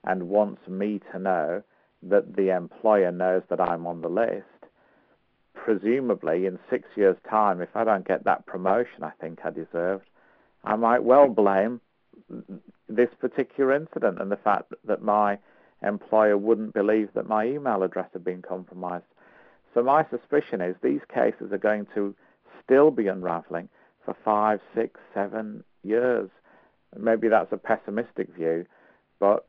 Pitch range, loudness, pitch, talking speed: 90-115 Hz, -25 LUFS, 100 Hz, 150 wpm